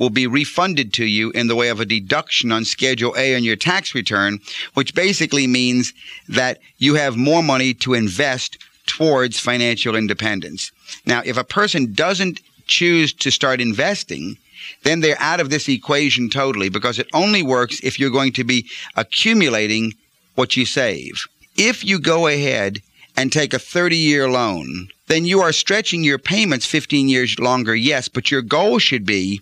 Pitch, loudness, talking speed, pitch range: 130 Hz, -17 LUFS, 170 wpm, 120-155 Hz